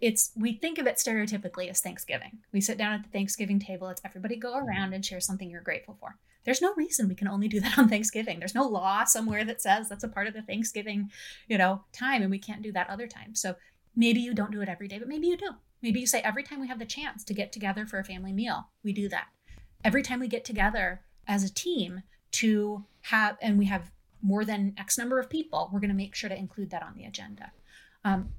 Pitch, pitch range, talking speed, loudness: 210 Hz, 195-235 Hz, 250 wpm, -29 LUFS